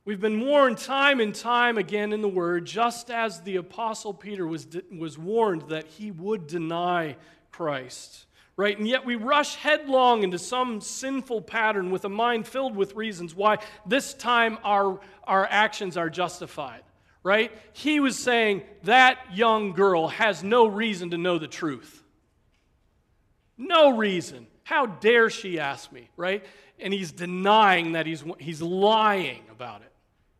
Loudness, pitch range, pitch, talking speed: -24 LUFS, 175-230 Hz, 205 Hz, 155 wpm